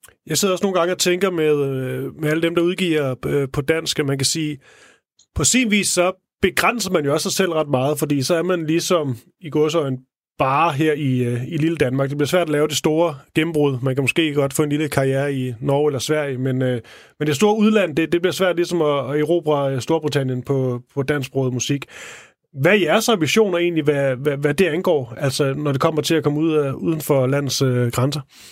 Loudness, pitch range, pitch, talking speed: -19 LUFS, 135-170 Hz, 150 Hz, 225 wpm